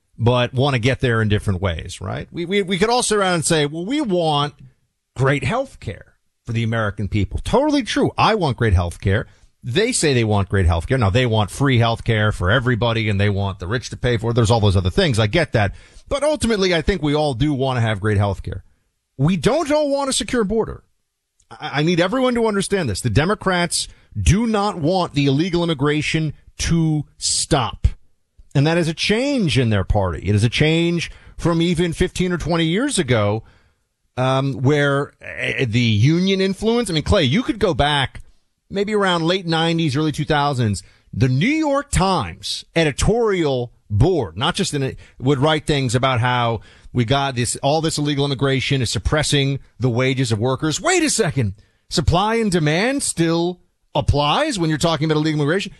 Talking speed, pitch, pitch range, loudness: 200 wpm, 140 Hz, 115-175 Hz, -19 LUFS